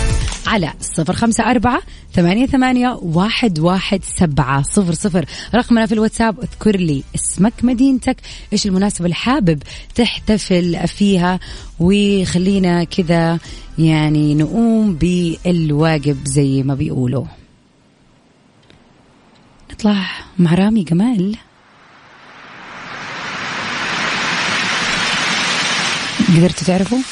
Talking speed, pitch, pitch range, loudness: 85 wpm, 185 Hz, 165-220 Hz, -16 LUFS